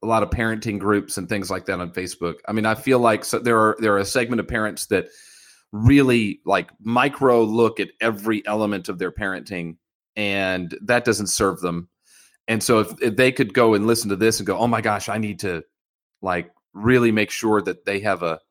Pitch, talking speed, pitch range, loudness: 110 Hz, 220 wpm, 100-115 Hz, -21 LUFS